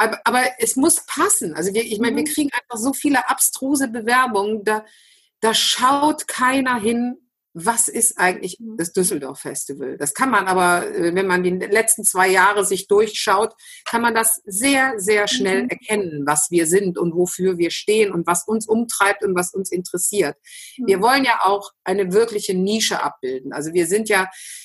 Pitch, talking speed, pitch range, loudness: 215 Hz, 175 wpm, 185-245 Hz, -18 LUFS